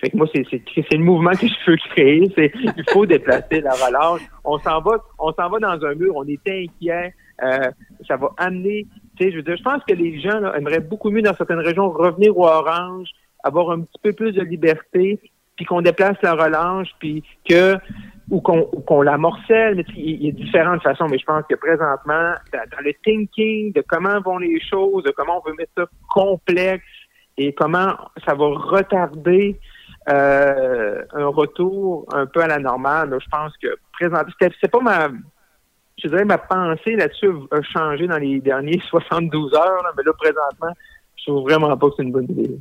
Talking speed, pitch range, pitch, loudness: 205 wpm, 155-195 Hz, 175 Hz, -18 LUFS